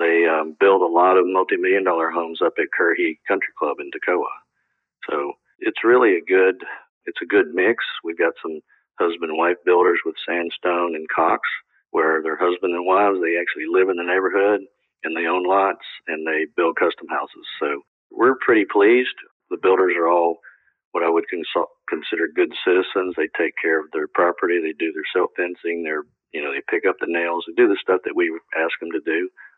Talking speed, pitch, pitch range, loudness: 200 wpm, 385 Hz, 345-415 Hz, -20 LUFS